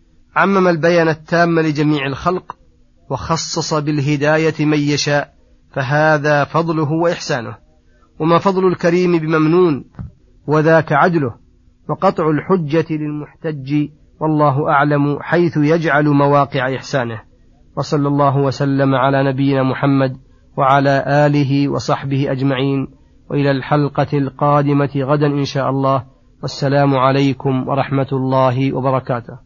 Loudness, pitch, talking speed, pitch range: -16 LUFS, 145 Hz, 100 wpm, 135-155 Hz